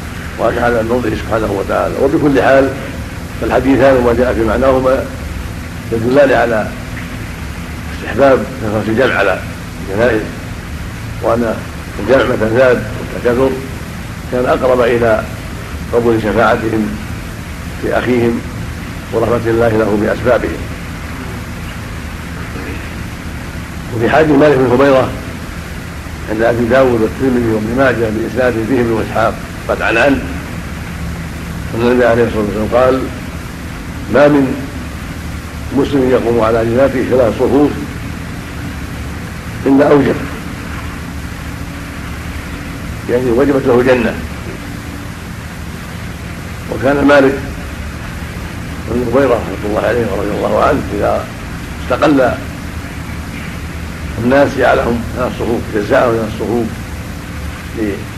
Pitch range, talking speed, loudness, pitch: 85-120 Hz, 90 wpm, -14 LUFS, 105 Hz